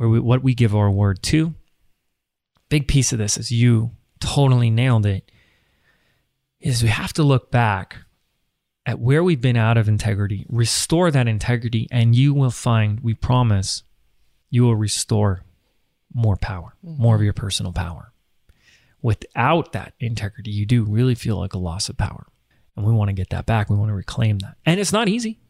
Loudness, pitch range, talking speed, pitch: -20 LUFS, 100-125 Hz, 175 wpm, 115 Hz